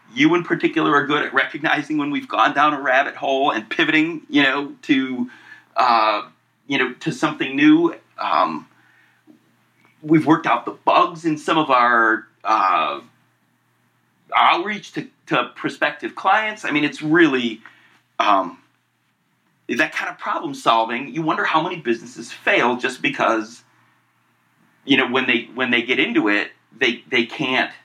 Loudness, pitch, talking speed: -19 LUFS, 270 Hz, 155 wpm